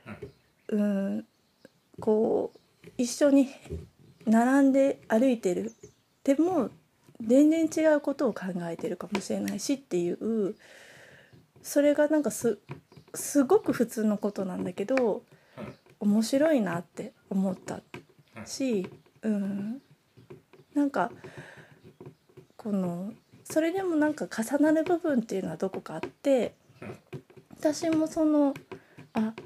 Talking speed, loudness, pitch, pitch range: 210 characters per minute, -28 LUFS, 240 Hz, 200-290 Hz